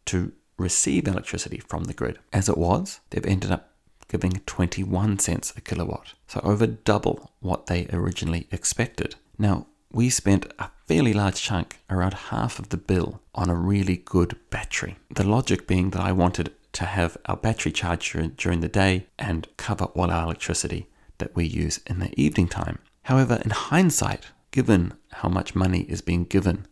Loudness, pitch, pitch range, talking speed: -25 LUFS, 95 Hz, 85-105 Hz, 175 wpm